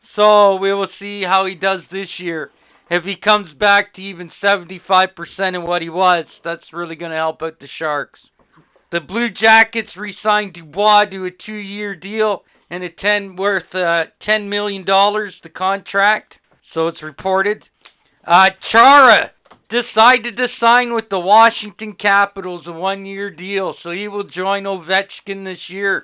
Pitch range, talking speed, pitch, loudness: 180-210 Hz, 165 wpm, 195 Hz, -16 LUFS